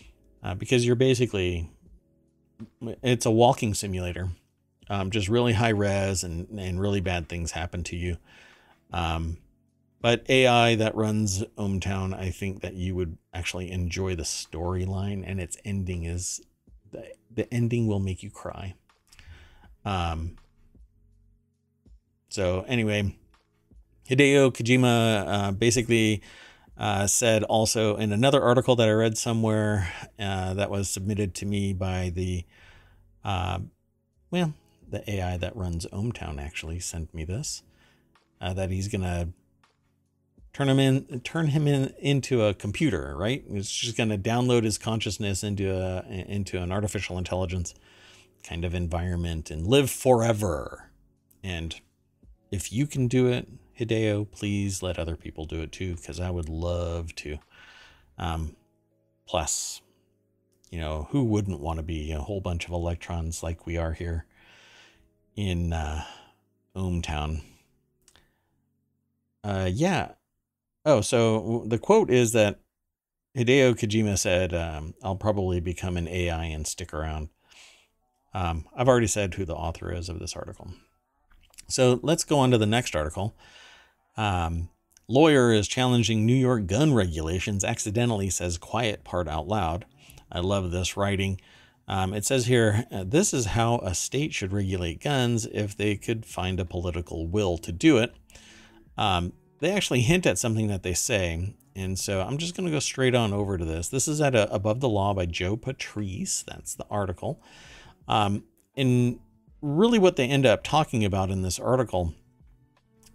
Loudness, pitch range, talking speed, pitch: -26 LUFS, 90-115 Hz, 150 wpm, 100 Hz